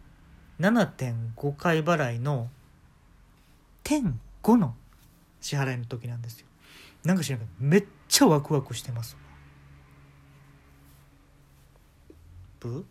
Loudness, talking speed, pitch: -27 LUFS, 170 characters per minute, 120 Hz